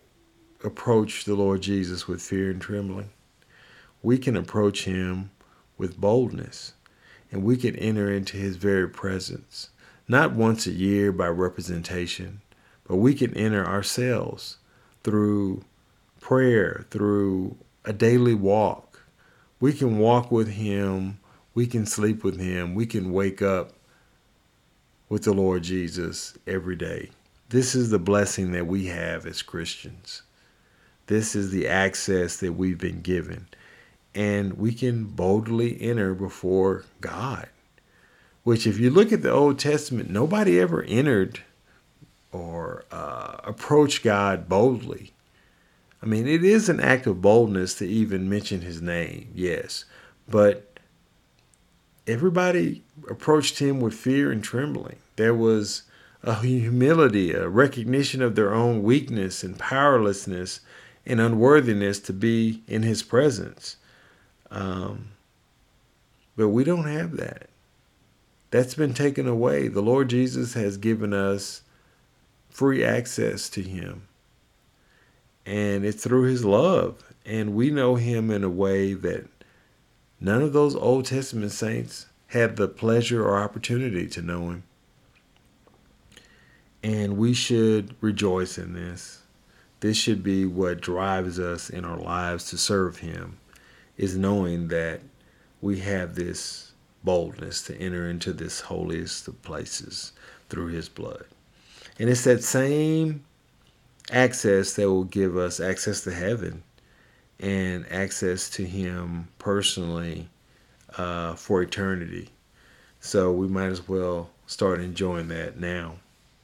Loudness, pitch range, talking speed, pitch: -24 LUFS, 95-115 Hz, 130 wpm, 100 Hz